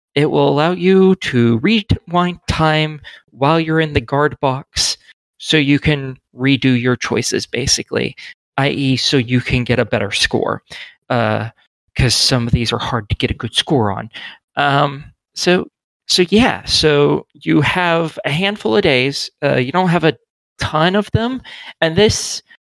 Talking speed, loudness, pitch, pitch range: 165 wpm, -16 LUFS, 145 Hz, 125-165 Hz